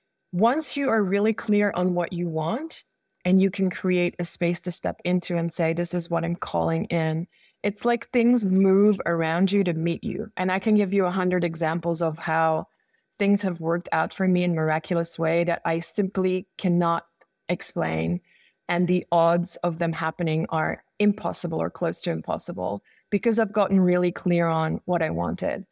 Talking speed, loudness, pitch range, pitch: 190 wpm, -24 LUFS, 170-195 Hz, 175 Hz